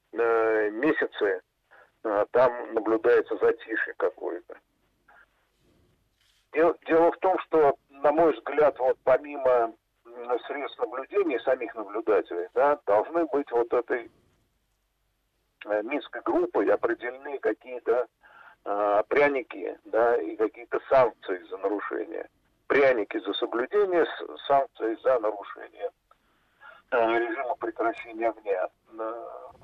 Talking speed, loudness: 85 wpm, -26 LUFS